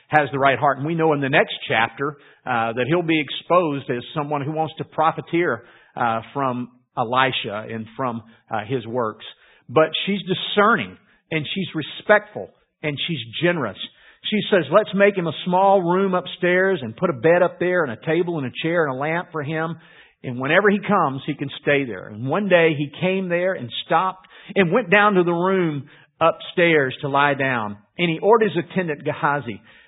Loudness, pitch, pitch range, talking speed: -21 LUFS, 160 Hz, 140-180 Hz, 195 wpm